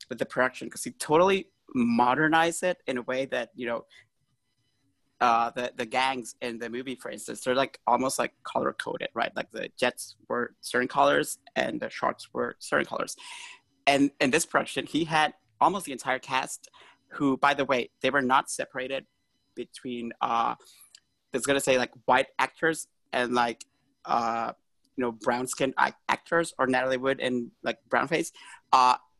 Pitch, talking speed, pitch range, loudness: 130 Hz, 175 wpm, 125-140 Hz, -27 LUFS